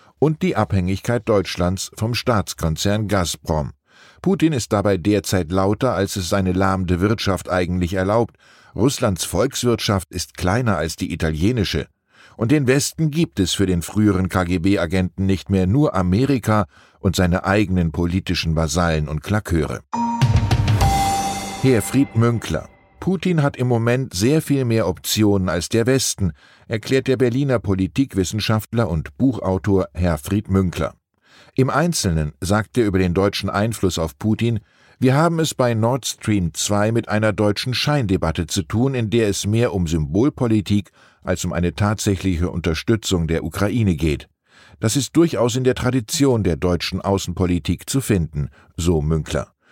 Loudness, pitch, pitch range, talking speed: -20 LUFS, 100 Hz, 90-115 Hz, 140 wpm